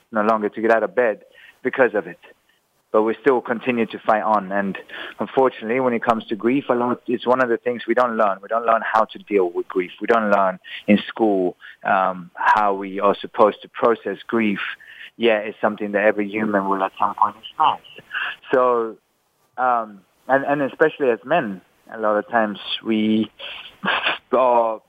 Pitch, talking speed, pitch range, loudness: 110 Hz, 195 wpm, 105-120 Hz, -20 LUFS